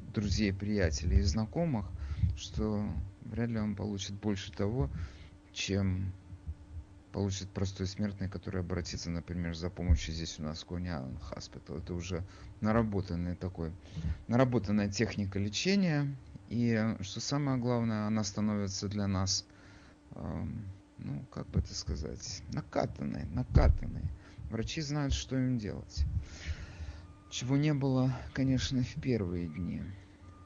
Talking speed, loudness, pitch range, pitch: 120 wpm, -34 LUFS, 85-110 Hz, 95 Hz